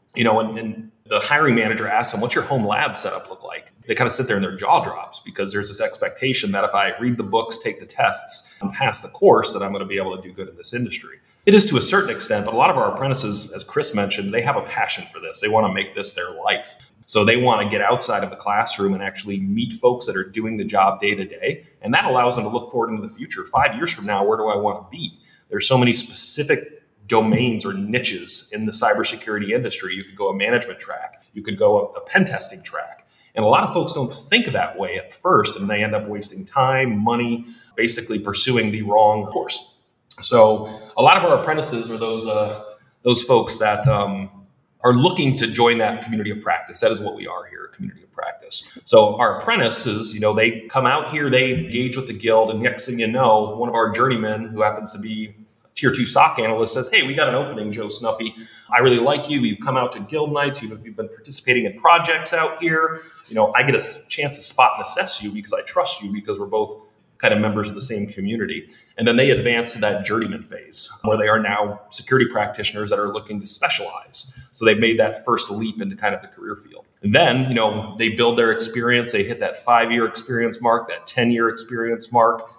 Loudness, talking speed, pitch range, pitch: -19 LUFS, 240 wpm, 110-130 Hz, 115 Hz